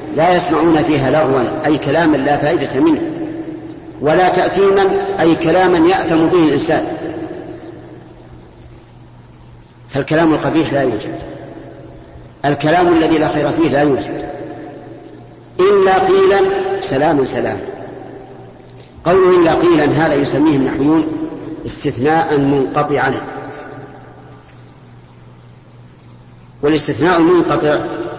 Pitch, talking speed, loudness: 160 Hz, 85 wpm, -14 LUFS